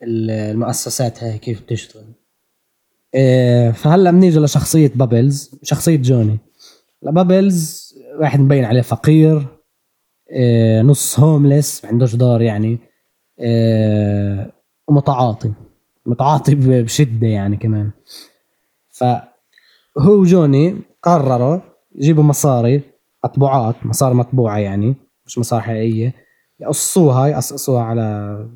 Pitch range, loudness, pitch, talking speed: 115-145 Hz, -14 LUFS, 125 Hz, 90 wpm